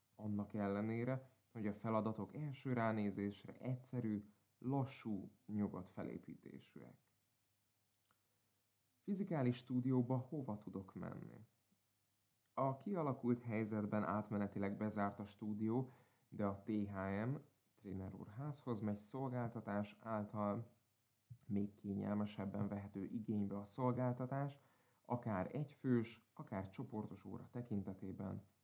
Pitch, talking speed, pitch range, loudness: 110 Hz, 90 wpm, 105-125 Hz, -44 LUFS